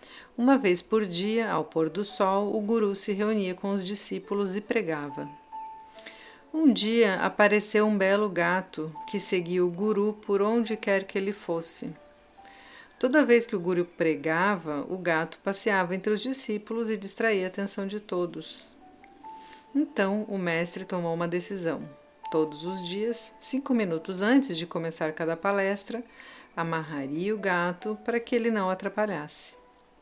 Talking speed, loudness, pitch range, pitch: 150 wpm, -27 LUFS, 175-225 Hz, 200 Hz